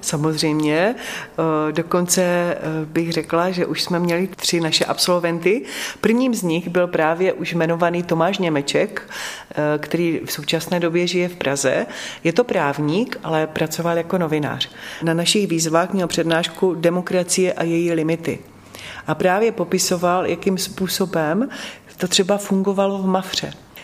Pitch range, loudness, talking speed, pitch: 160-185 Hz, -20 LUFS, 135 wpm, 170 Hz